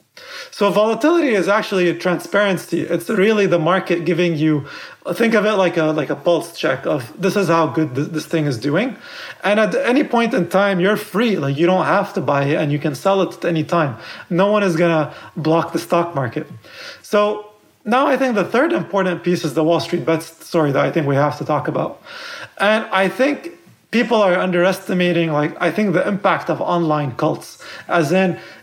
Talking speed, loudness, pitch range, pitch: 215 wpm, -18 LUFS, 160-205 Hz, 180 Hz